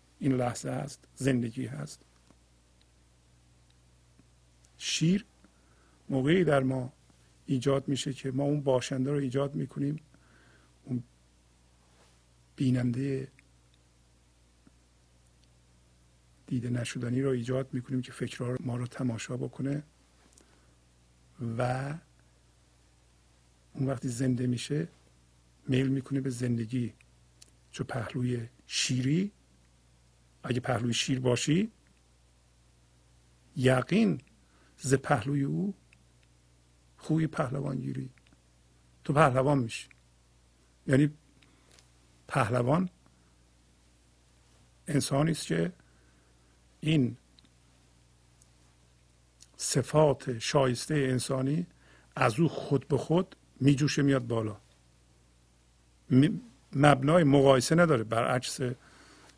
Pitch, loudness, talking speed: 110 Hz, -30 LUFS, 80 wpm